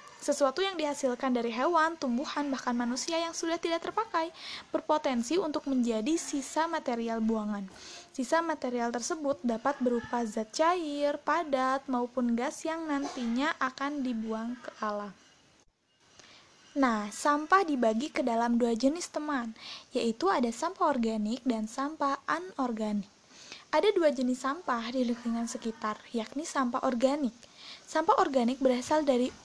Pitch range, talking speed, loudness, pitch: 240-310 Hz, 130 wpm, -31 LUFS, 265 Hz